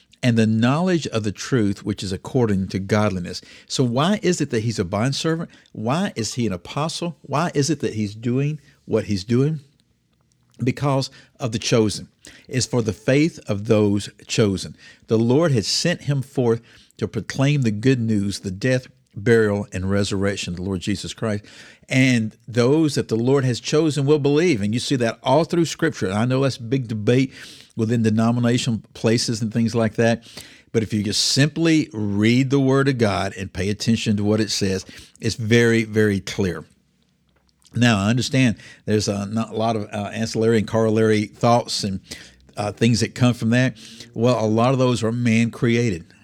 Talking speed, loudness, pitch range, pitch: 185 wpm, -21 LUFS, 105-130 Hz, 115 Hz